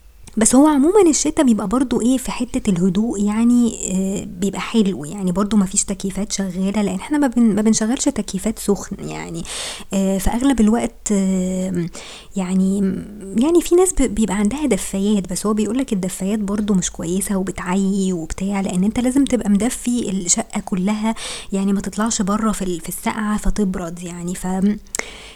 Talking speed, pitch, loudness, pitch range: 145 wpm, 205 Hz, -19 LUFS, 190-225 Hz